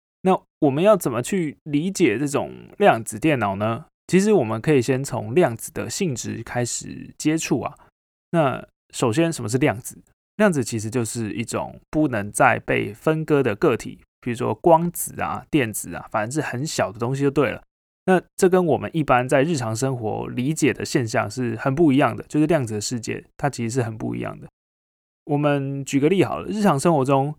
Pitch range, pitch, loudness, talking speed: 120-160 Hz, 140 Hz, -22 LUFS, 285 characters per minute